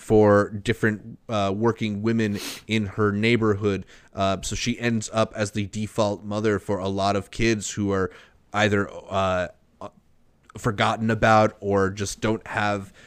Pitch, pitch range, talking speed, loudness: 105 Hz, 100-110 Hz, 145 wpm, -24 LUFS